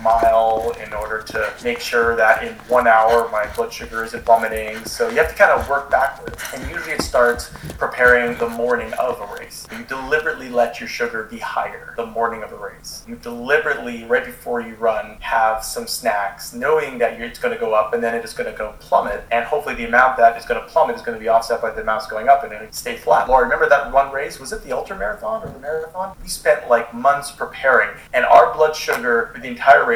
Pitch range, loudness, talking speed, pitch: 115-140 Hz, -19 LUFS, 235 wpm, 120 Hz